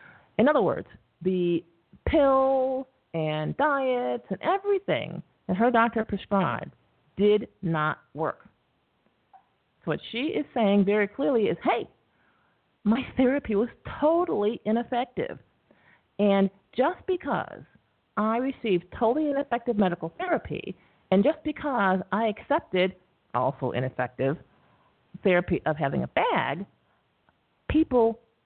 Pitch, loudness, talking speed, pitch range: 210 Hz, -26 LUFS, 110 wpm, 180-260 Hz